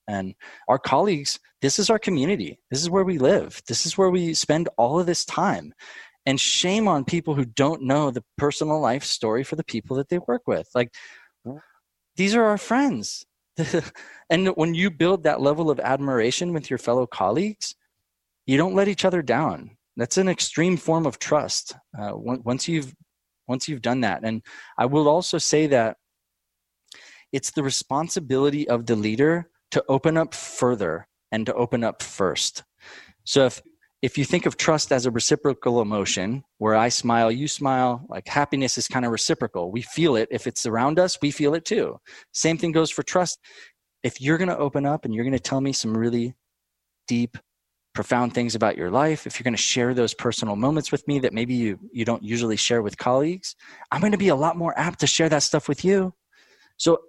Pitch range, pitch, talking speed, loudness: 120-165 Hz, 140 Hz, 200 wpm, -23 LUFS